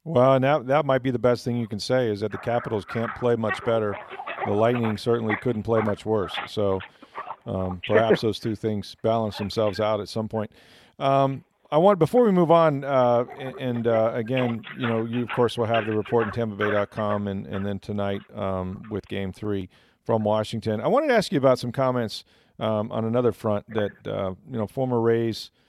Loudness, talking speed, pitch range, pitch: -24 LUFS, 210 wpm, 105-125 Hz, 115 Hz